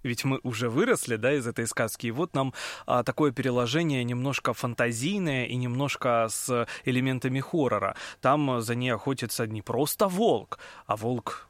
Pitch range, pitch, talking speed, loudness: 120-135 Hz, 125 Hz, 155 wpm, -28 LUFS